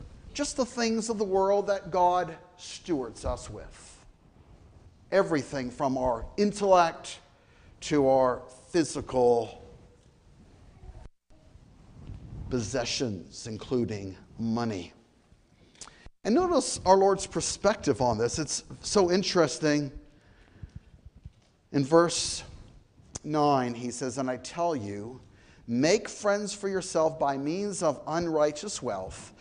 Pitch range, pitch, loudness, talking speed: 115-175 Hz, 140 Hz, -28 LUFS, 100 wpm